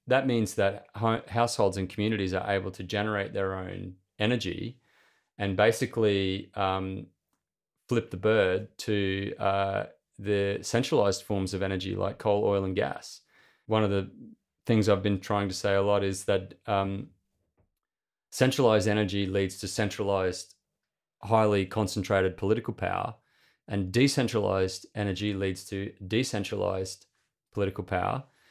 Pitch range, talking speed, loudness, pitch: 95-110 Hz, 130 wpm, -28 LUFS, 100 Hz